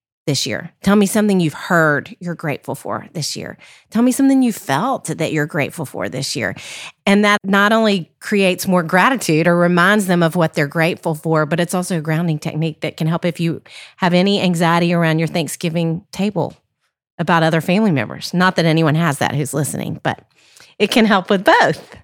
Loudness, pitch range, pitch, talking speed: -17 LUFS, 160-190 Hz, 170 Hz, 200 wpm